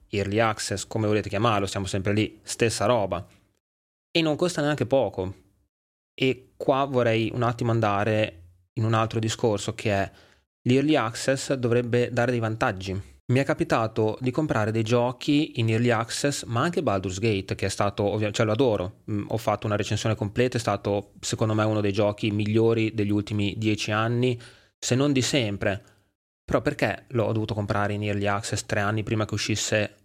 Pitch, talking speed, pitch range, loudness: 110 Hz, 180 wpm, 100-120 Hz, -25 LUFS